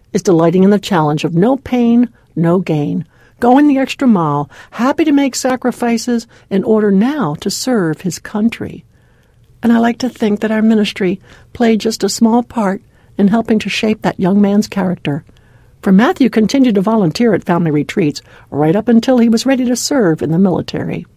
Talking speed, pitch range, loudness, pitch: 185 wpm, 175-235 Hz, -13 LUFS, 210 Hz